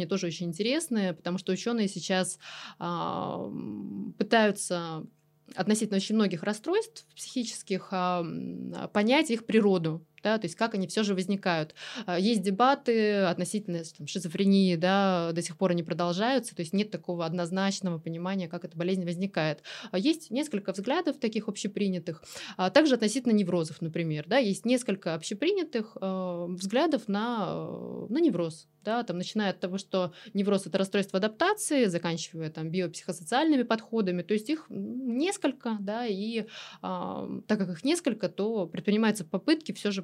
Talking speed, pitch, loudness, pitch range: 140 wpm, 195 Hz, -29 LUFS, 180-225 Hz